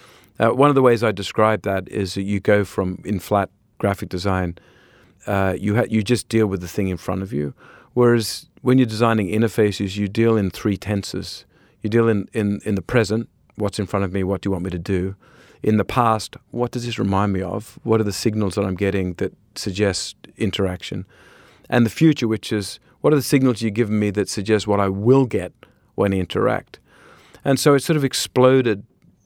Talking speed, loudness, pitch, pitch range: 215 wpm, -20 LUFS, 105 Hz, 95-115 Hz